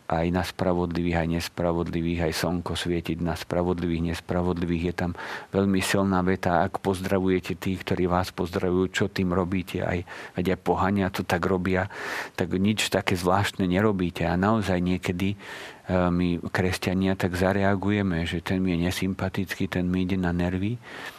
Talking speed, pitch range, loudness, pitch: 150 wpm, 90-95 Hz, -26 LUFS, 90 Hz